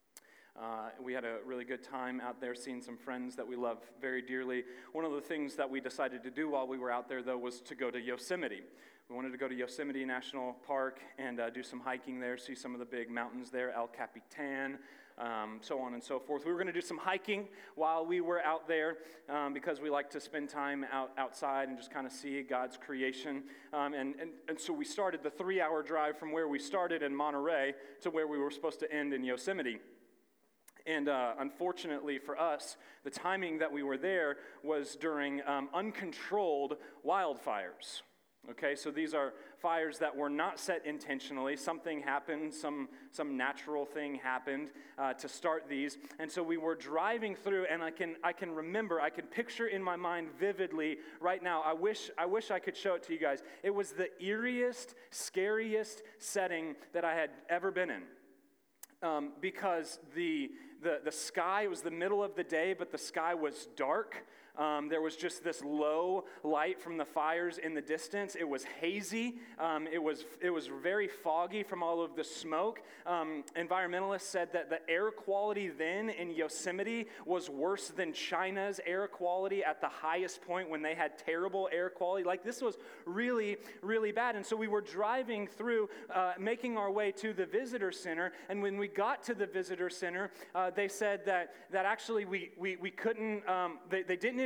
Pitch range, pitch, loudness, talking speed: 140-190 Hz, 160 Hz, -37 LUFS, 200 wpm